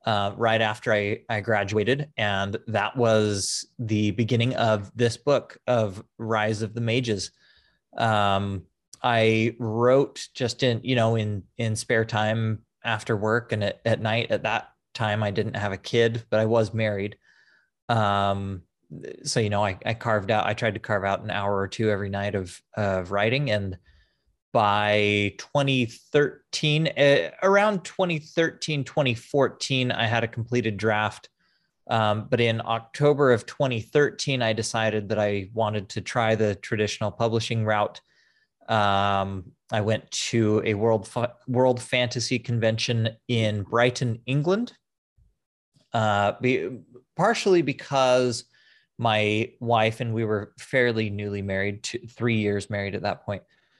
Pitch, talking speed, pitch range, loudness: 110 Hz, 145 wpm, 105-120 Hz, -25 LUFS